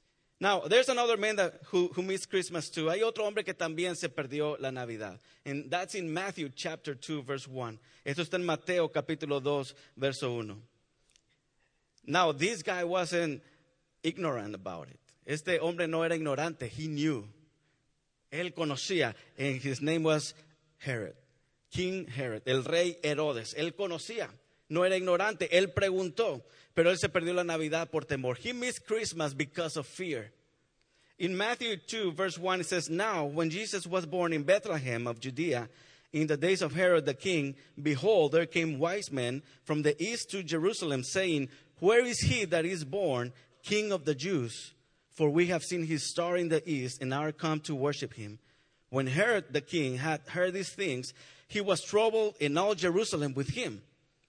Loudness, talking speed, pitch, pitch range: -32 LUFS, 175 wpm, 160 Hz, 140-180 Hz